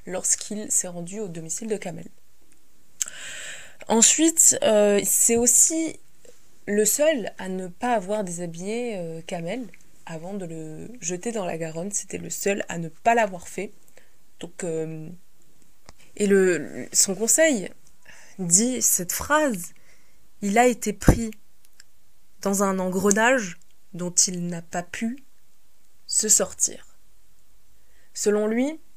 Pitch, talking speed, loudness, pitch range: 205 Hz, 125 wpm, -22 LUFS, 180-230 Hz